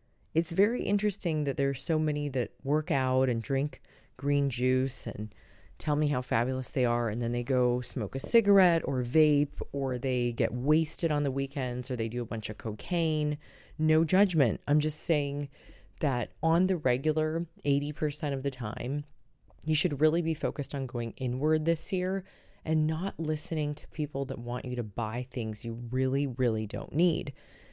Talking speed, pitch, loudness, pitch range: 180 wpm, 140 Hz, -30 LUFS, 125-155 Hz